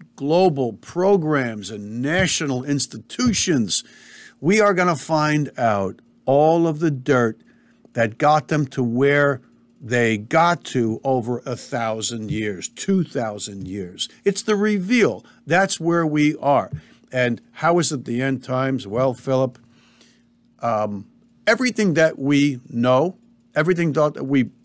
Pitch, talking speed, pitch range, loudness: 140 Hz, 130 wpm, 120-165 Hz, -20 LUFS